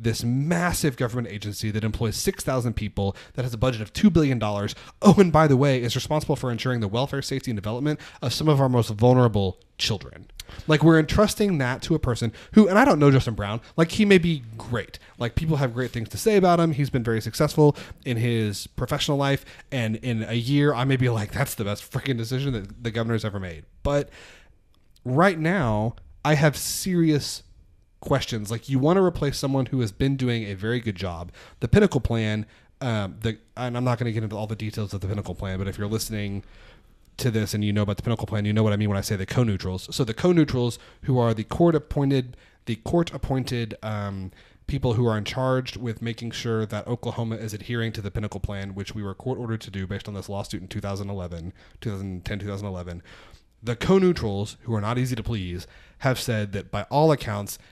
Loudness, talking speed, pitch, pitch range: -24 LUFS, 220 wpm, 115 Hz, 105-135 Hz